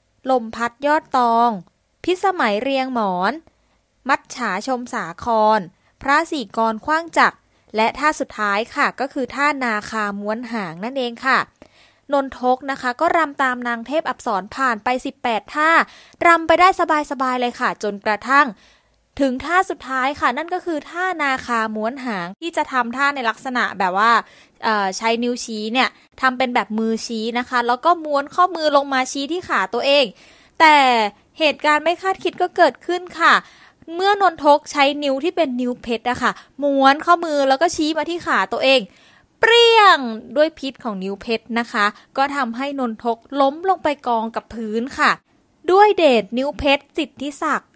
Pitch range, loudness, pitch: 230-310 Hz, -19 LUFS, 265 Hz